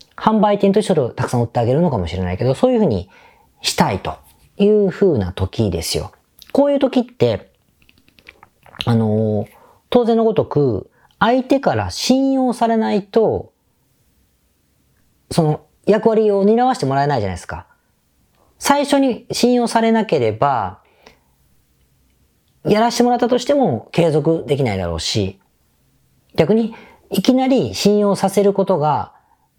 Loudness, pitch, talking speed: -17 LUFS, 195 Hz, 285 characters per minute